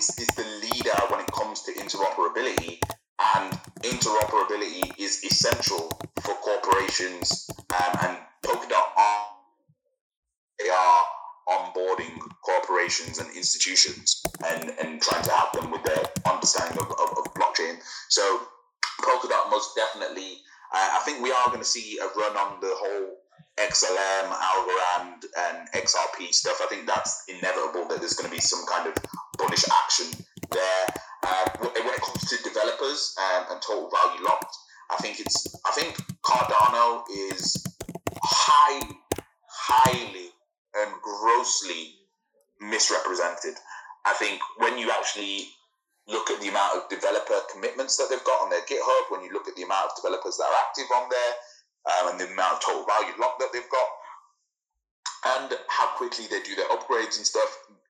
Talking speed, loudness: 155 wpm, -25 LUFS